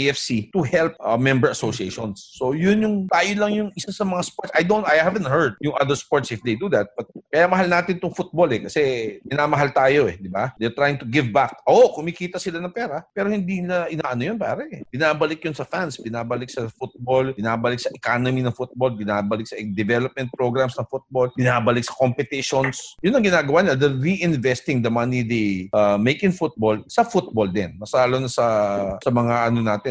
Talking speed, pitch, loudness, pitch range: 205 wpm, 130 Hz, -21 LUFS, 120-175 Hz